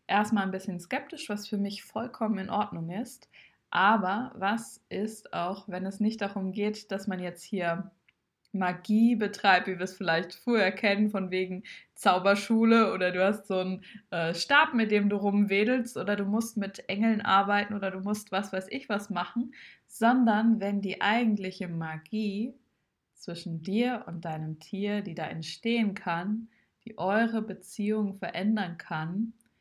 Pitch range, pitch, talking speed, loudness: 185-220 Hz, 205 Hz, 160 wpm, -29 LUFS